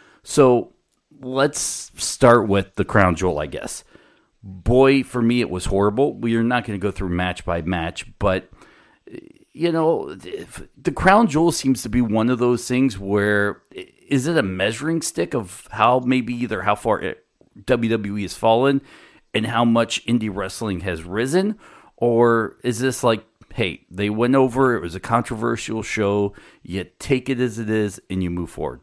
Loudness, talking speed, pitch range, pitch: -20 LUFS, 175 wpm, 100-130 Hz, 115 Hz